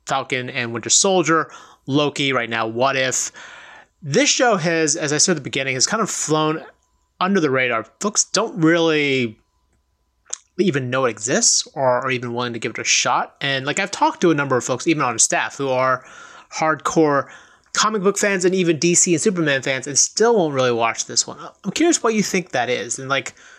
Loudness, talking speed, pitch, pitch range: -18 LUFS, 205 wpm, 145 Hz, 130-175 Hz